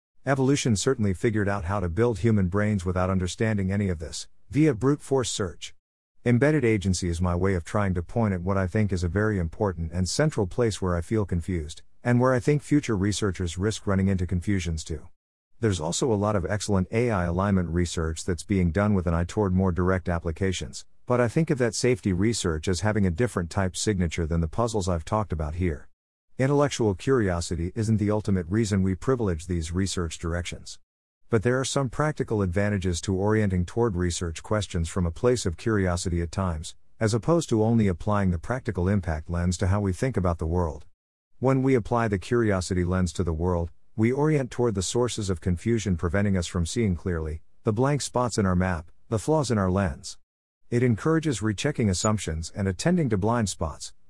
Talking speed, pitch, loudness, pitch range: 195 wpm, 95 Hz, -26 LUFS, 90-115 Hz